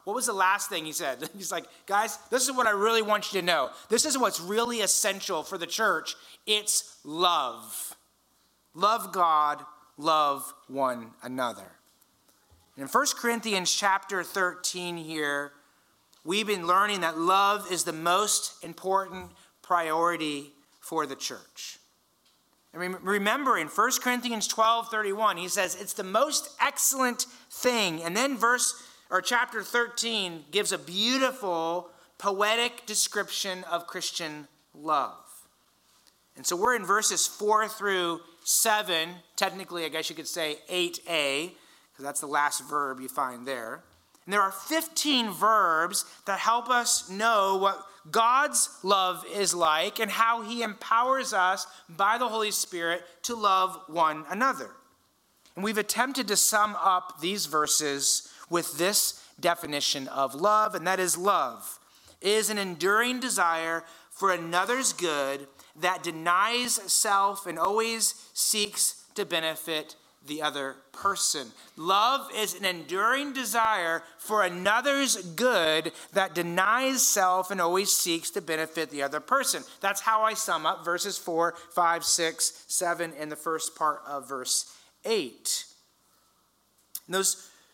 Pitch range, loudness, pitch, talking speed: 165-220 Hz, -27 LUFS, 190 Hz, 140 wpm